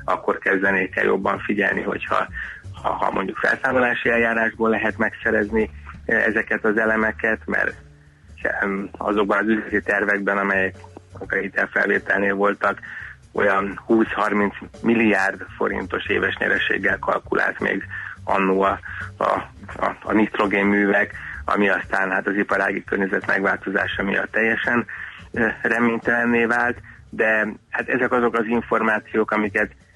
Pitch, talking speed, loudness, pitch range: 105 Hz, 115 wpm, -21 LUFS, 95-110 Hz